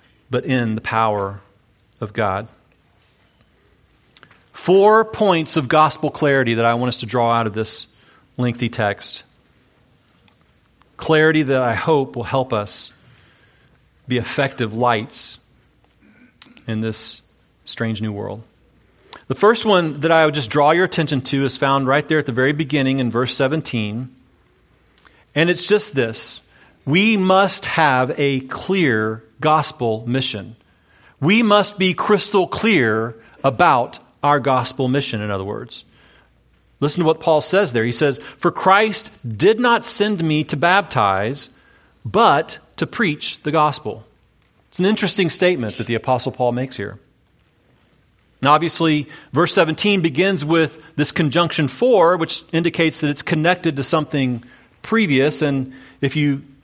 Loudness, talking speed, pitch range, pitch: -18 LUFS, 140 wpm, 115-165 Hz, 140 Hz